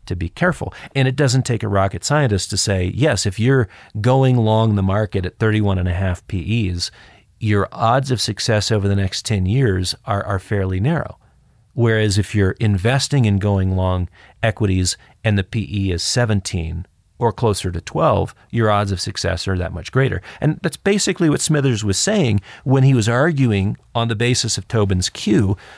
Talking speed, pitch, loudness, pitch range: 185 wpm, 105 Hz, -18 LUFS, 95-120 Hz